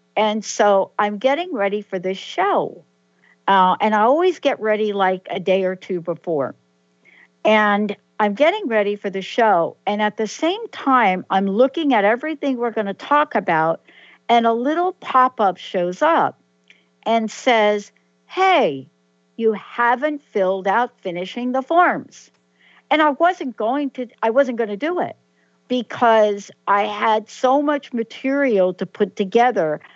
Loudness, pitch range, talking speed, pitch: -19 LUFS, 190-255 Hz, 155 wpm, 215 Hz